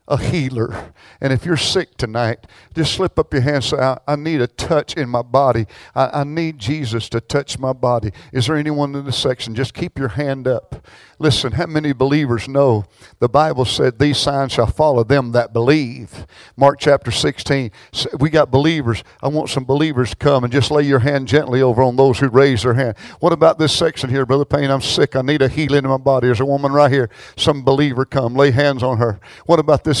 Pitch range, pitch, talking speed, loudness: 125-145 Hz, 135 Hz, 225 wpm, -17 LUFS